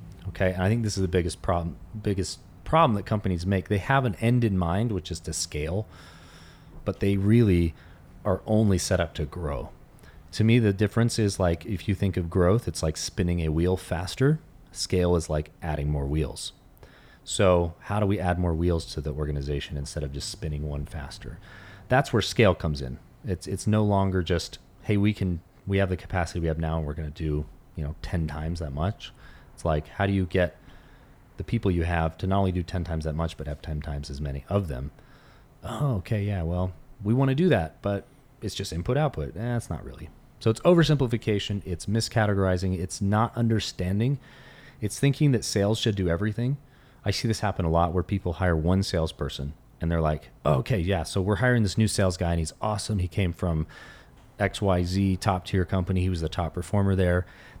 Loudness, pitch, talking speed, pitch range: -27 LUFS, 95 Hz, 210 wpm, 85-105 Hz